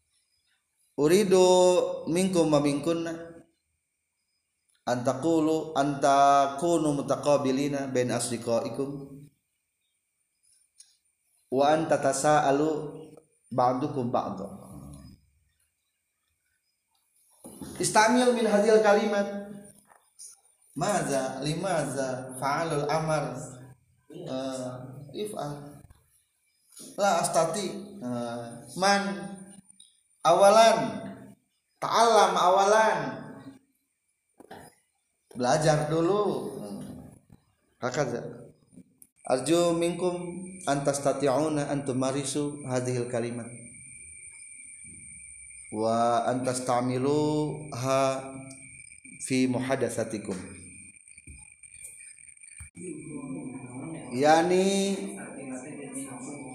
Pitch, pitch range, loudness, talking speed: 140 Hz, 125-170 Hz, -26 LUFS, 55 wpm